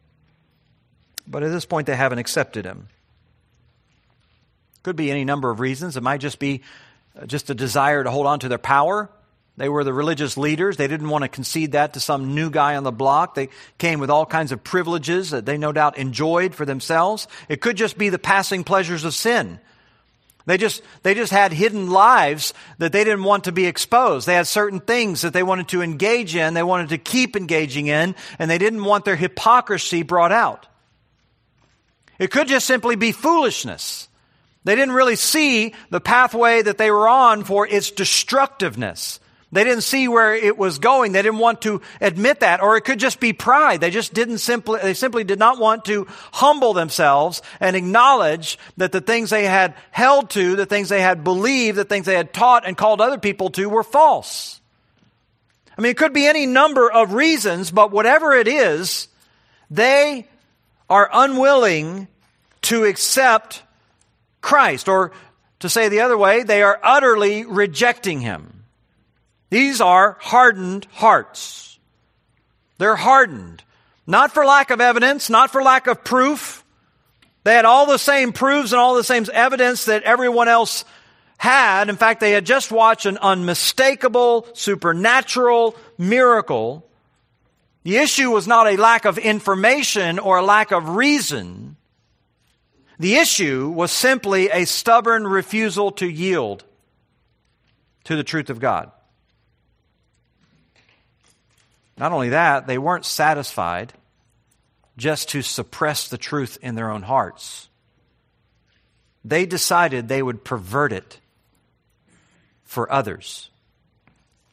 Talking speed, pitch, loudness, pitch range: 160 wpm, 195 Hz, -17 LUFS, 150-230 Hz